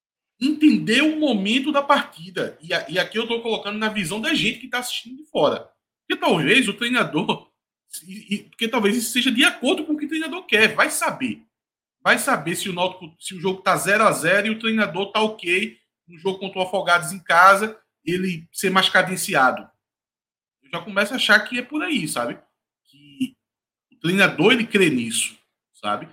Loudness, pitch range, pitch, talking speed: -20 LUFS, 185-250 Hz, 210 Hz, 195 wpm